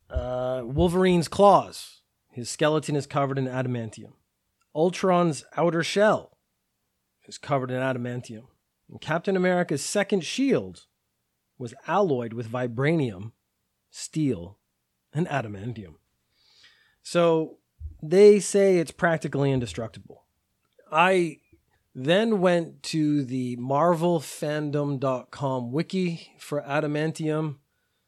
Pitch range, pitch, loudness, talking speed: 125-170 Hz, 145 Hz, -25 LUFS, 90 wpm